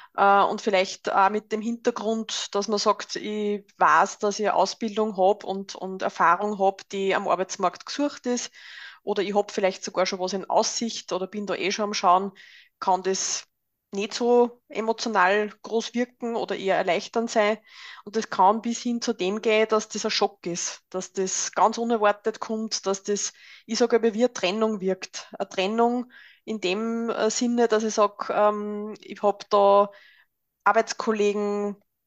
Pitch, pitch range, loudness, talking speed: 210 Hz, 195-225 Hz, -25 LUFS, 170 wpm